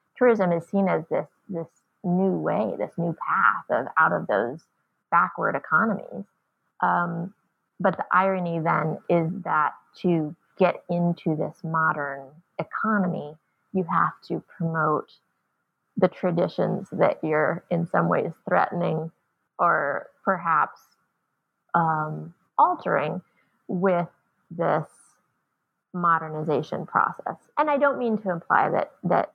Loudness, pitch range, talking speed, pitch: -25 LUFS, 160-190 Hz, 120 wpm, 175 Hz